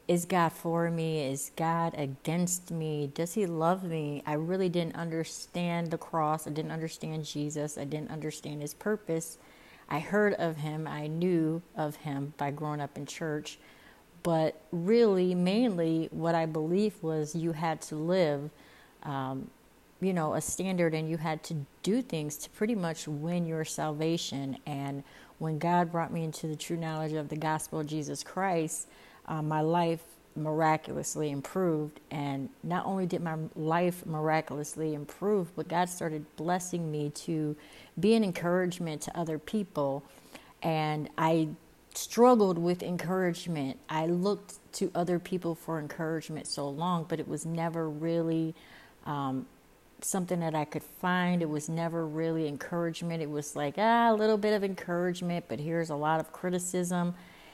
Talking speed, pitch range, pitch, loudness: 160 wpm, 155-175 Hz, 160 Hz, -32 LUFS